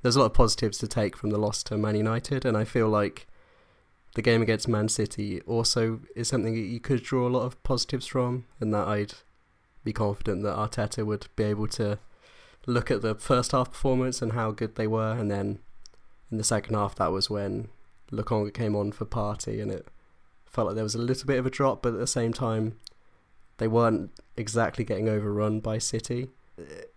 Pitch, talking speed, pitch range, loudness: 110 Hz, 210 wpm, 105-125 Hz, -28 LUFS